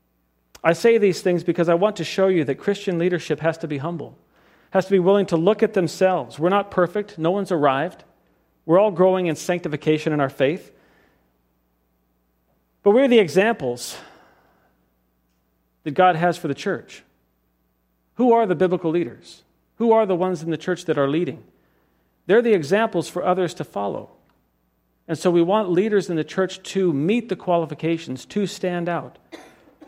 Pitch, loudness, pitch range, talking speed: 170 Hz, -21 LUFS, 140-190 Hz, 175 wpm